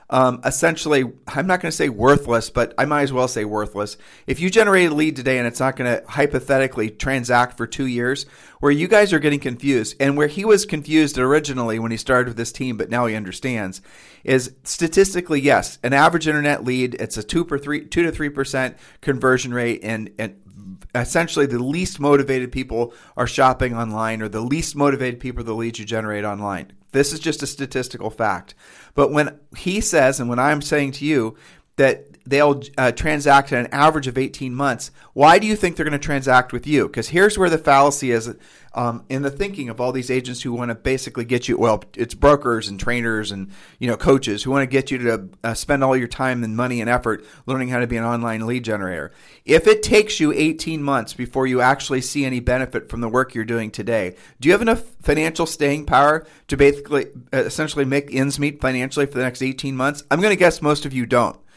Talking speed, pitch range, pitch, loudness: 220 wpm, 120-145 Hz, 130 Hz, -19 LUFS